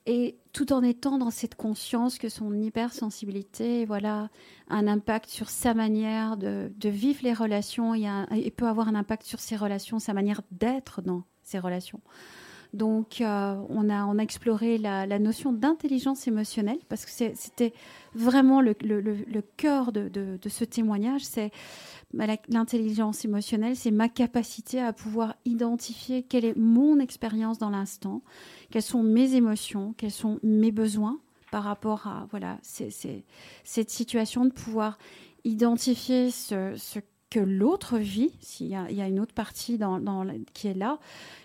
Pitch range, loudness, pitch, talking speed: 210-240 Hz, -28 LUFS, 220 Hz, 170 wpm